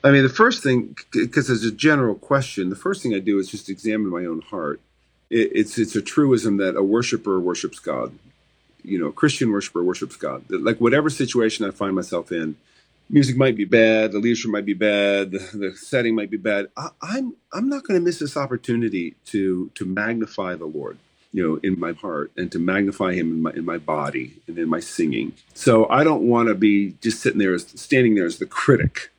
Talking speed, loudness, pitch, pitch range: 220 wpm, -21 LUFS, 110 Hz, 100-135 Hz